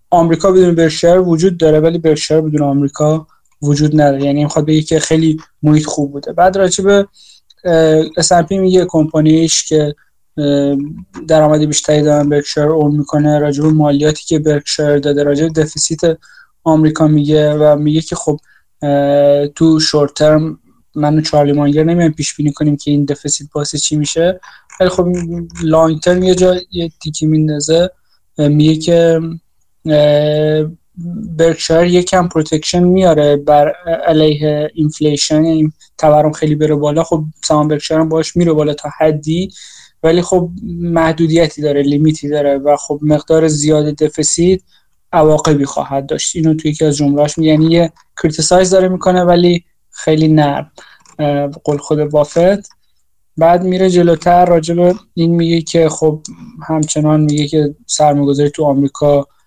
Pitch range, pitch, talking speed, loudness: 150-165 Hz, 155 Hz, 140 wpm, -12 LUFS